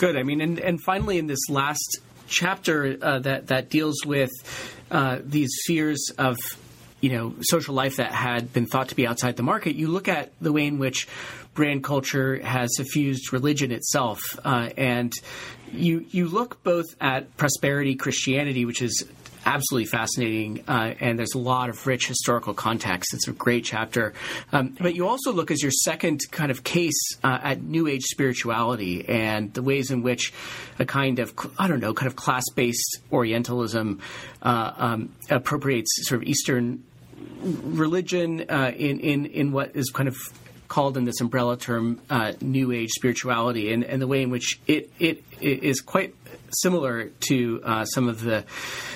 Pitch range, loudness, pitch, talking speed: 120-150 Hz, -25 LUFS, 130 Hz, 180 wpm